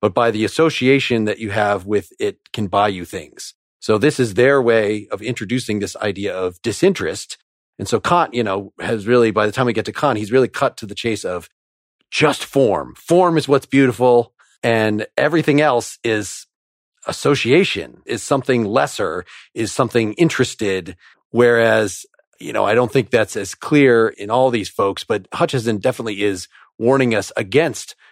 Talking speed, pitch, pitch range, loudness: 175 wpm, 115 Hz, 105-130 Hz, -18 LUFS